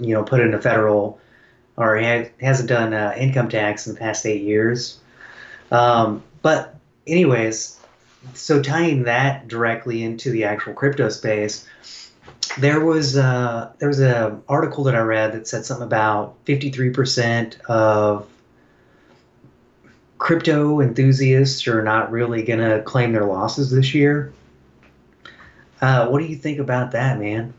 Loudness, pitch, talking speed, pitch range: -19 LUFS, 120 Hz, 145 wpm, 110-135 Hz